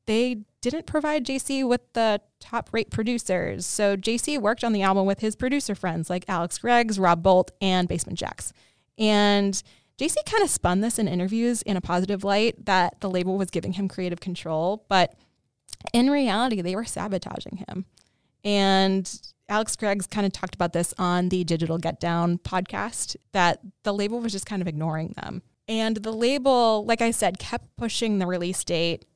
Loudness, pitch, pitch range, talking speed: -25 LUFS, 200 Hz, 185-230 Hz, 180 wpm